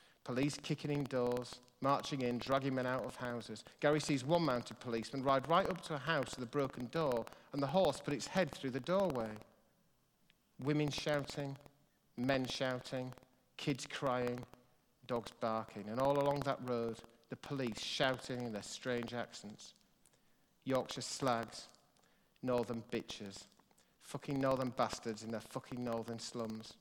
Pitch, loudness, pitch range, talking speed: 130 Hz, -39 LUFS, 120-140 Hz, 150 wpm